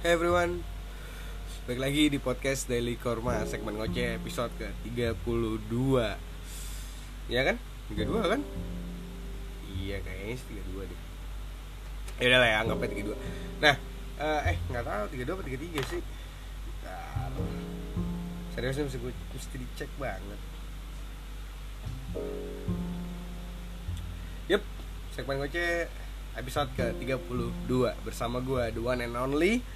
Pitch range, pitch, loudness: 85-125 Hz, 95 Hz, -32 LUFS